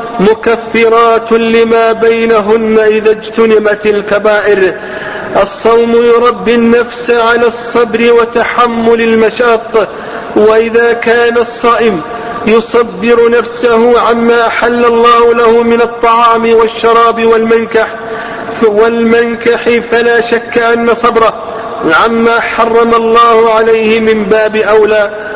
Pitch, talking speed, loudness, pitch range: 230 Hz, 90 wpm, -8 LUFS, 225-235 Hz